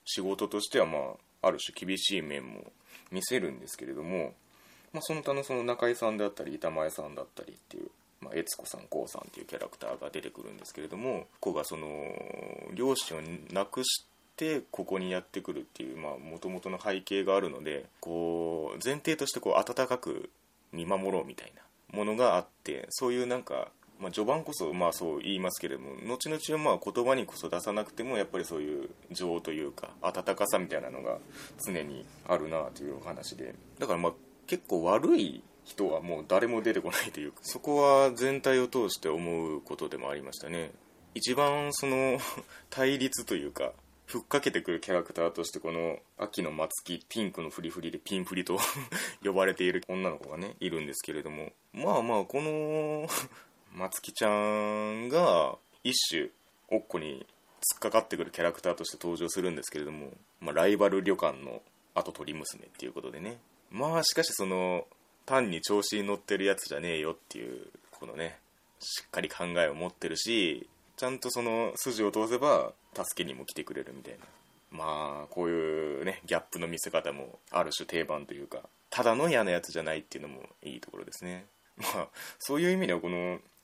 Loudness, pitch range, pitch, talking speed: -32 LUFS, 90-135 Hz, 105 Hz, 380 characters per minute